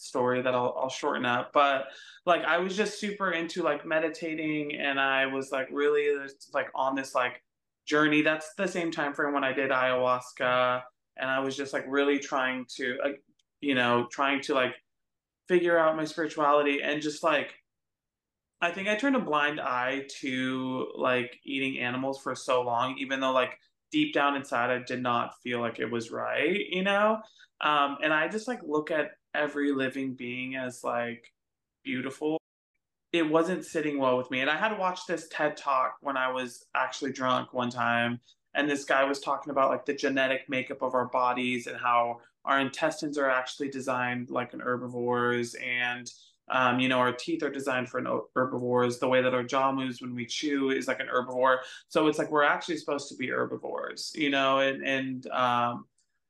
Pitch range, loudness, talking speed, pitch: 125-150 Hz, -29 LUFS, 190 wpm, 135 Hz